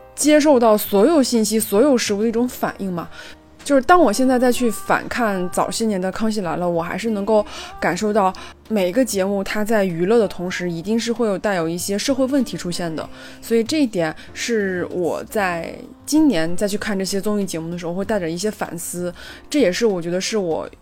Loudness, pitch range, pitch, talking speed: -19 LUFS, 180-235 Hz, 210 Hz, 310 characters per minute